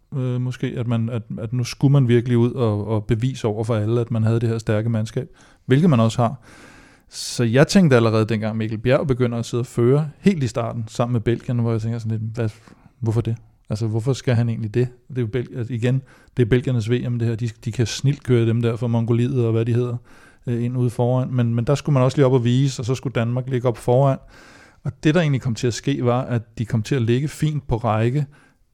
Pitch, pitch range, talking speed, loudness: 120 Hz, 115-130 Hz, 255 wpm, -21 LUFS